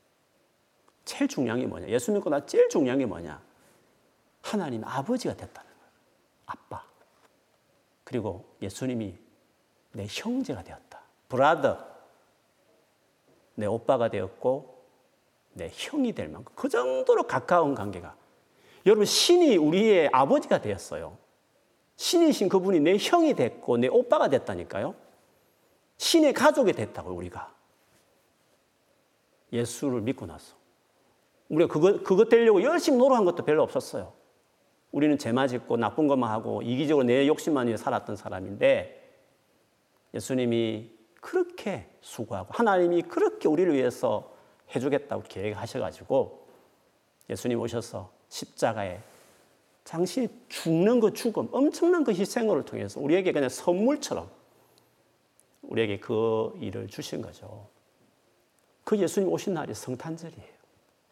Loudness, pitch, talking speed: -26 LUFS, 185 Hz, 275 characters per minute